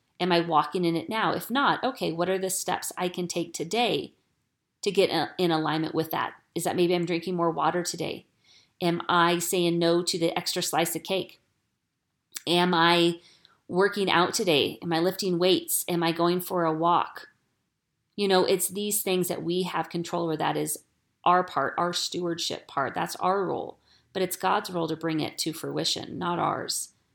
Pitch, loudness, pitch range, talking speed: 175 Hz, -26 LUFS, 165-180 Hz, 190 wpm